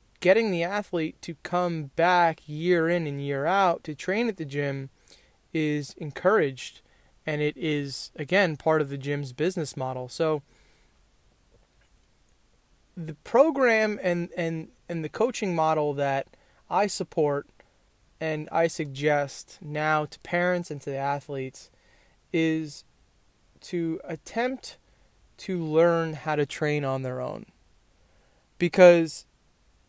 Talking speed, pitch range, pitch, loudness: 125 wpm, 140-175 Hz, 155 Hz, -26 LUFS